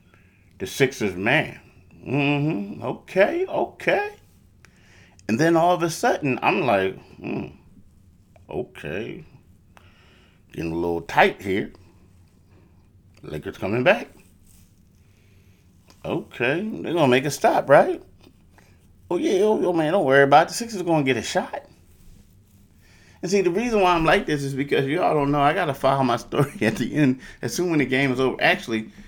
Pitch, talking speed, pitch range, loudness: 100 Hz, 160 wpm, 90-145 Hz, -22 LUFS